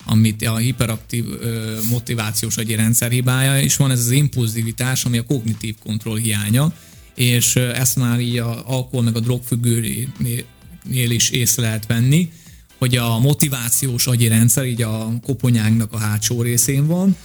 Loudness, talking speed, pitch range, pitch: -18 LUFS, 140 wpm, 115-130 Hz, 120 Hz